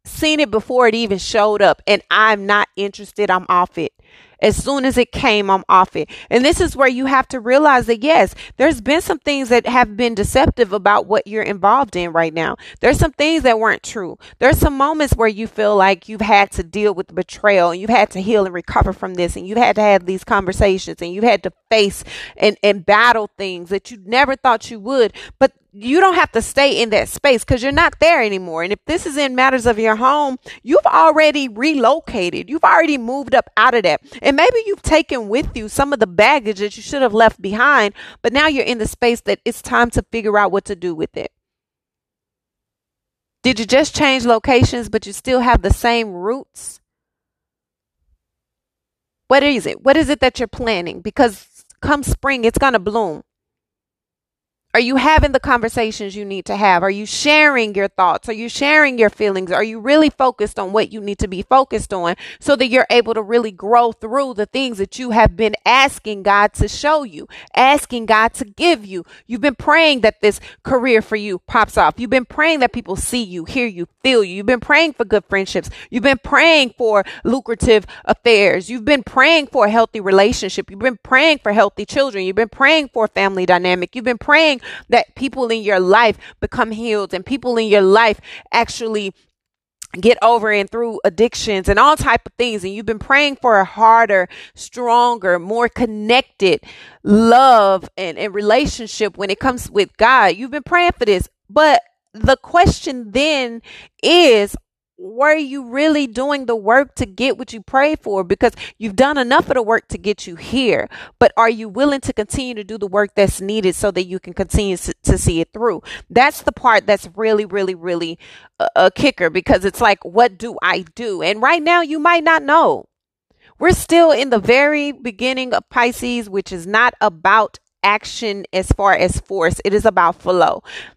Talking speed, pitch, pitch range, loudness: 205 wpm, 230 Hz, 205-270 Hz, -15 LUFS